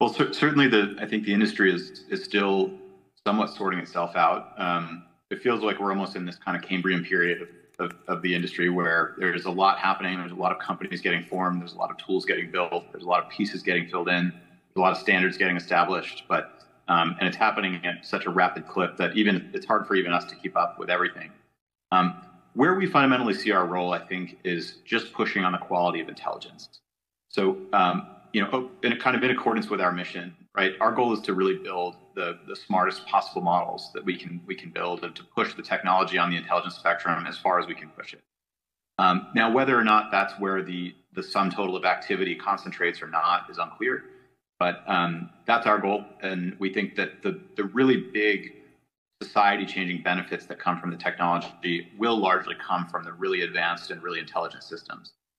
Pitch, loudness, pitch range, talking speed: 95 Hz, -26 LUFS, 90-105 Hz, 220 wpm